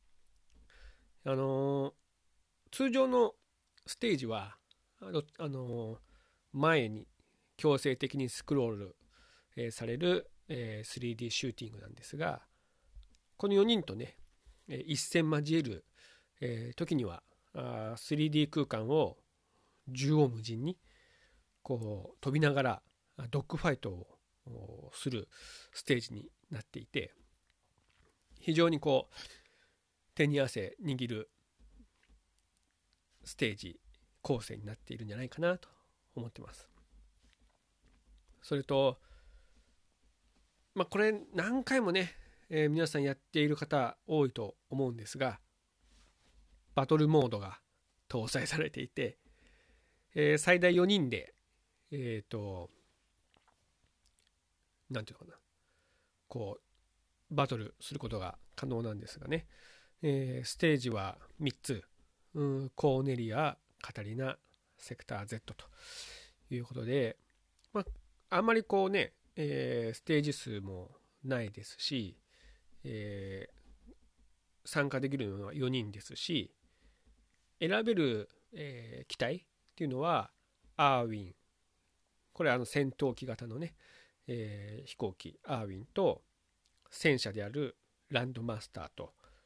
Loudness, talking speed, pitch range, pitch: -35 LUFS, 225 characters per minute, 100-150 Hz, 125 Hz